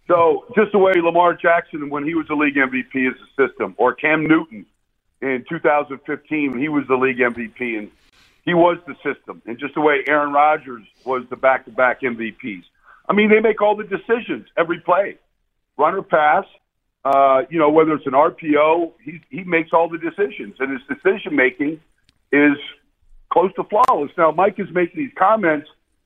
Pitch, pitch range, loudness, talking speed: 150 Hz, 135-175 Hz, -18 LUFS, 185 wpm